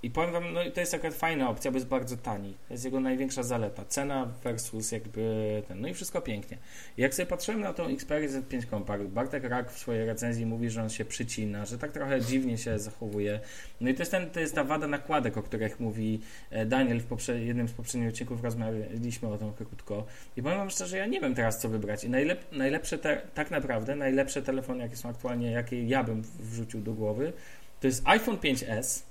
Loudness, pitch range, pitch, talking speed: -32 LUFS, 110-135 Hz, 120 Hz, 220 wpm